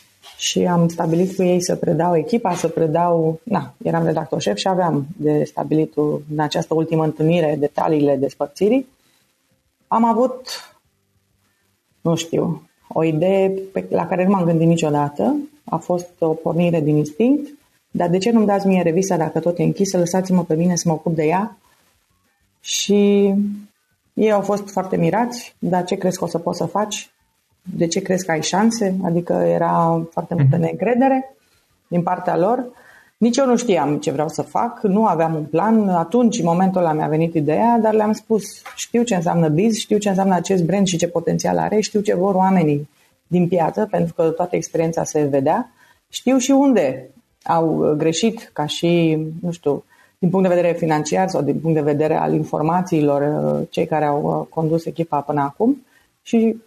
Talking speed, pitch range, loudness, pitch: 175 wpm, 160-200 Hz, -19 LUFS, 175 Hz